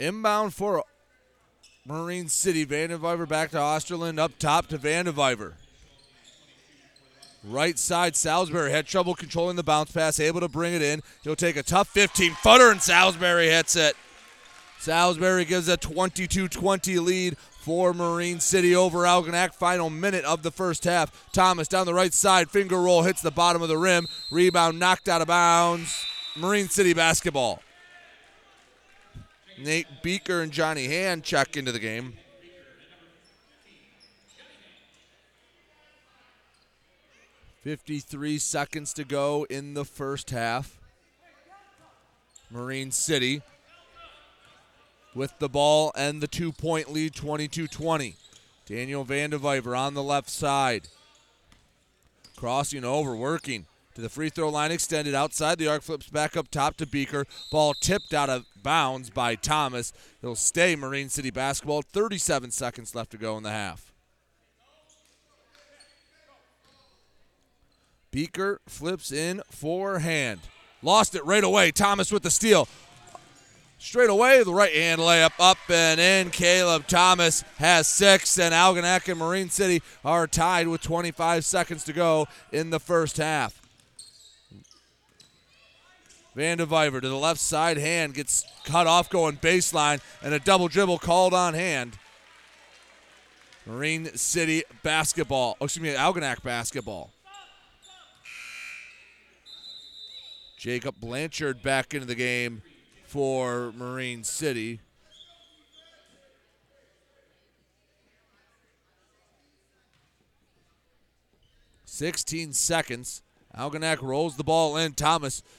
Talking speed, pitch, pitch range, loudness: 120 wpm, 160 Hz, 140-175 Hz, -24 LUFS